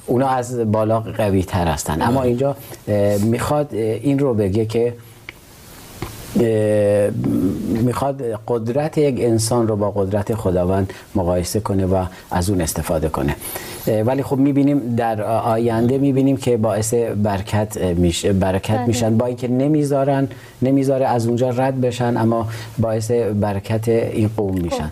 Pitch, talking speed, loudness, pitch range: 115 Hz, 130 wpm, -19 LUFS, 105-125 Hz